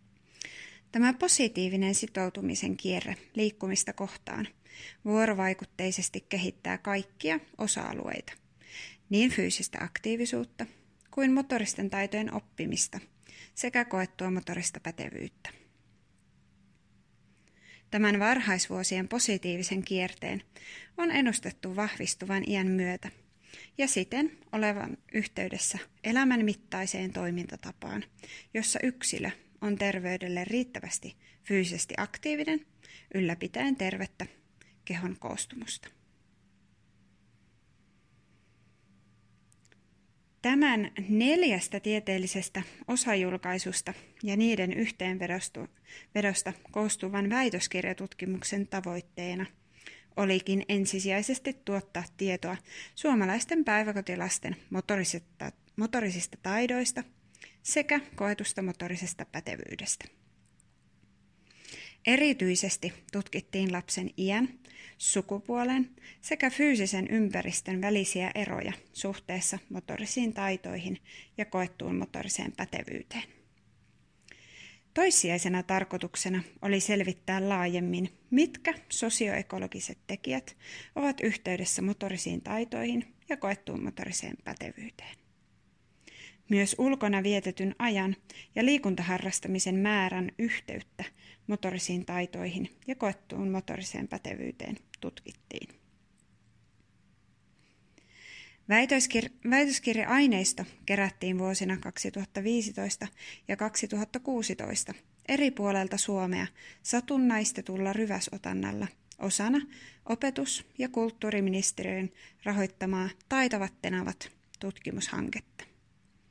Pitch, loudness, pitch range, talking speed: 195 Hz, -31 LUFS, 185-225 Hz, 70 wpm